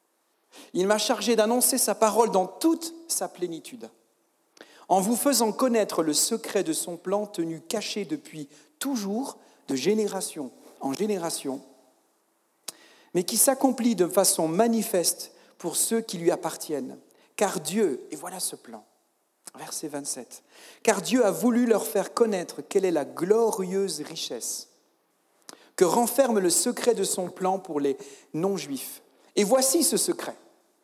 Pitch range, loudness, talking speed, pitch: 180-245 Hz, -25 LUFS, 140 wpm, 210 Hz